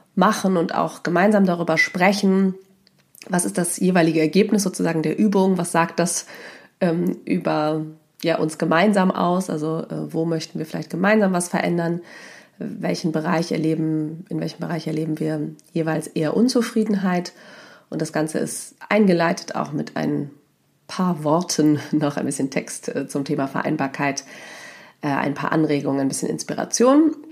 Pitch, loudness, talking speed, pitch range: 165 Hz, -21 LUFS, 150 wpm, 155-185 Hz